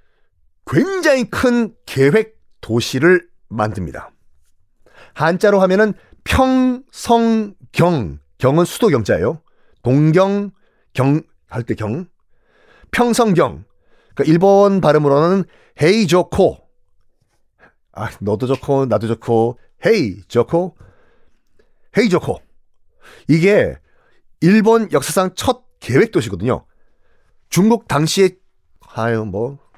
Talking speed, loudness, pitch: 190 characters per minute, -16 LUFS, 170 Hz